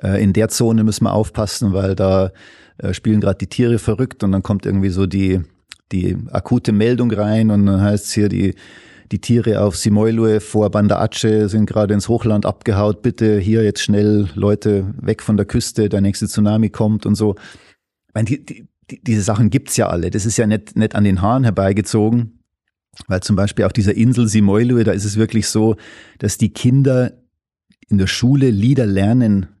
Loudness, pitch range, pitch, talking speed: -16 LUFS, 100-115 Hz, 105 Hz, 190 wpm